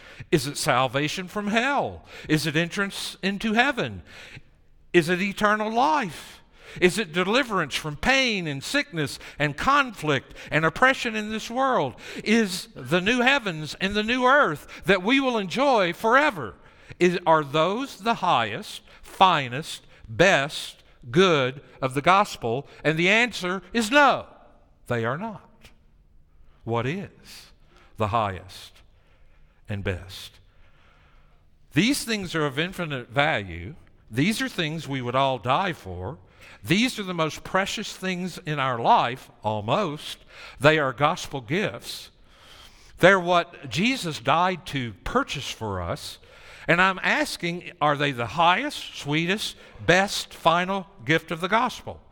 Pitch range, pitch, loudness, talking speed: 125-200 Hz, 160 Hz, -23 LUFS, 135 wpm